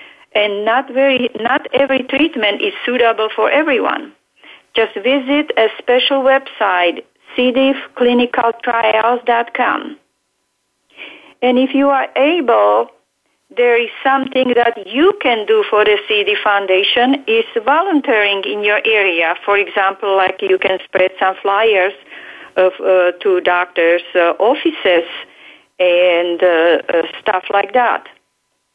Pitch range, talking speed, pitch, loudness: 195-270 Hz, 120 wpm, 225 Hz, -14 LUFS